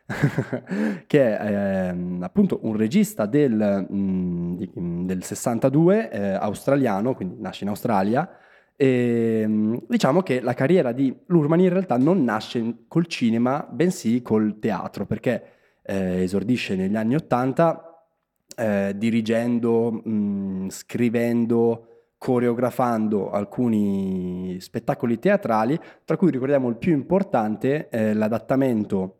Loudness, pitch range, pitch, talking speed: -23 LUFS, 105-145 Hz, 115 Hz, 115 wpm